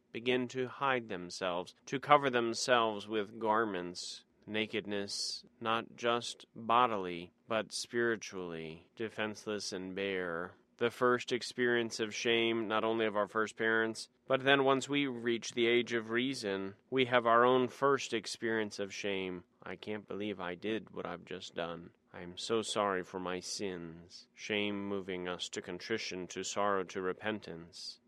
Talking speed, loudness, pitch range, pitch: 150 wpm, -34 LUFS, 95-120 Hz, 110 Hz